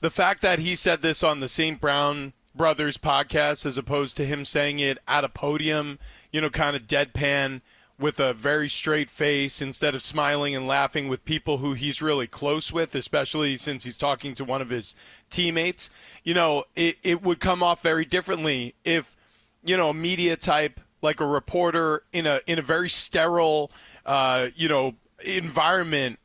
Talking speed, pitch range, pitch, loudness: 185 wpm, 140-165 Hz, 150 Hz, -24 LUFS